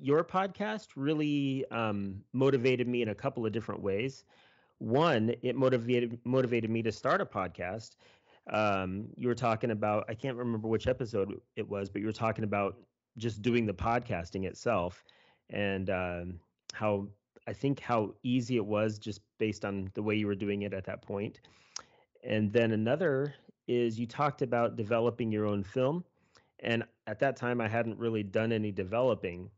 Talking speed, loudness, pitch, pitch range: 170 wpm, -32 LUFS, 115 Hz, 105-125 Hz